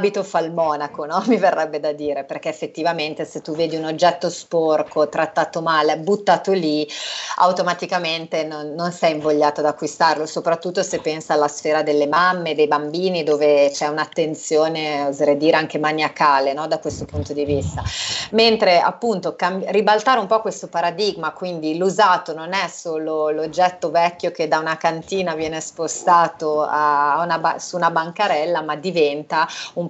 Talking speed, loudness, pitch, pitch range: 160 wpm, -19 LUFS, 160 Hz, 150-175 Hz